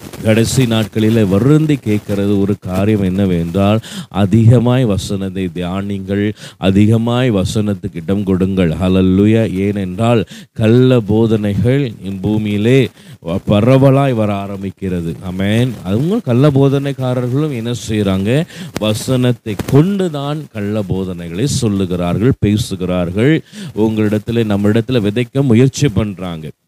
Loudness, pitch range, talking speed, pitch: -14 LUFS, 100-125 Hz, 90 wpm, 110 Hz